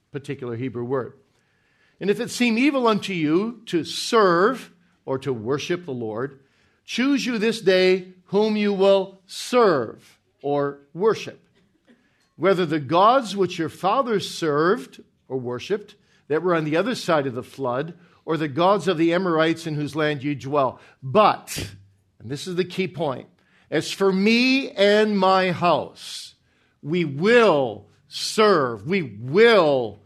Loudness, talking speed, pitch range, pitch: -21 LUFS, 150 wpm, 140-200 Hz, 170 Hz